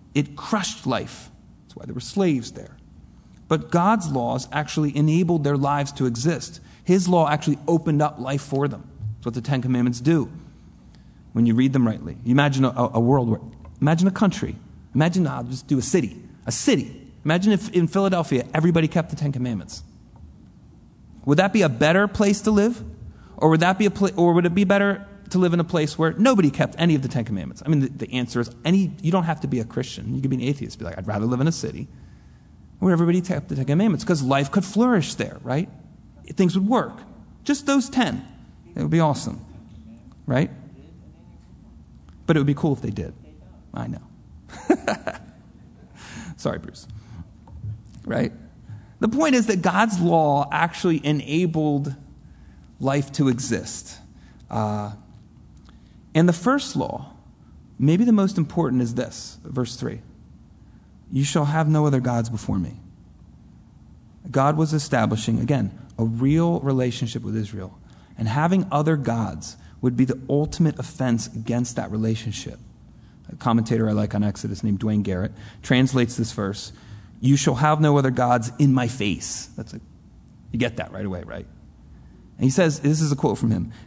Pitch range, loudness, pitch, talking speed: 115-165 Hz, -22 LUFS, 135 Hz, 180 wpm